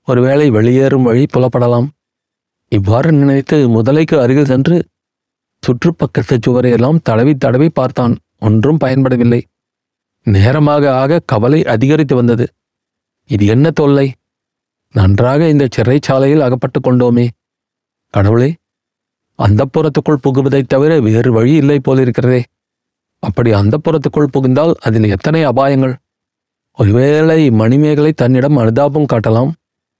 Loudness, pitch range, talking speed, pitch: -11 LUFS, 120-145 Hz, 95 wpm, 130 Hz